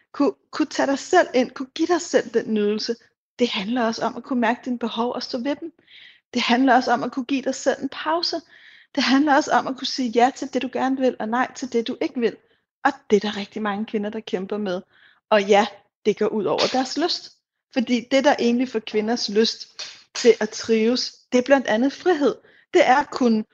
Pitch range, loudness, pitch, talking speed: 225-275 Hz, -22 LUFS, 250 Hz, 230 wpm